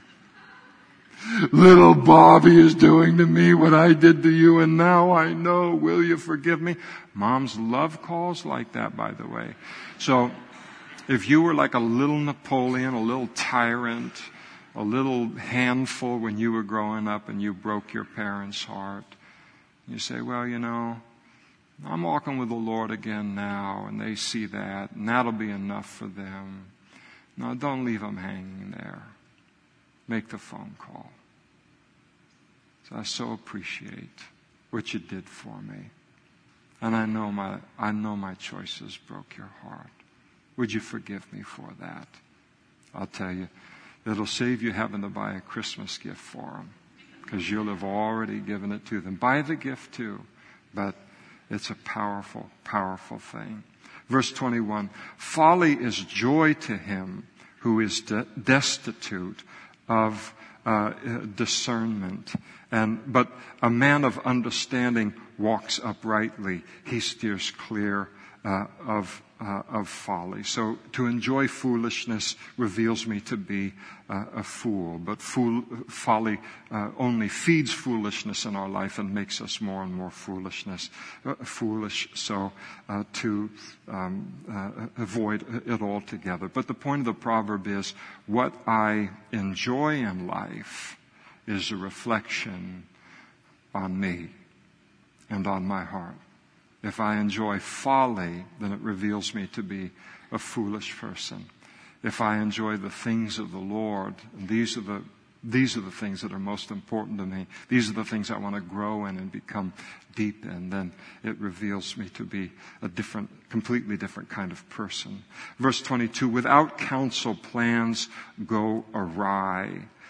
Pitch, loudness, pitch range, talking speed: 110 Hz, -25 LUFS, 100-125 Hz, 150 wpm